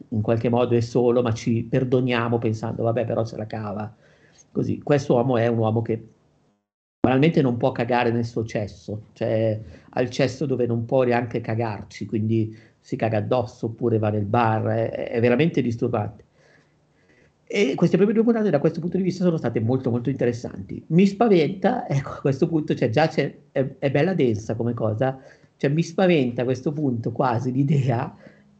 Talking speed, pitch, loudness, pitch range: 180 wpm, 120 Hz, -23 LUFS, 115-140 Hz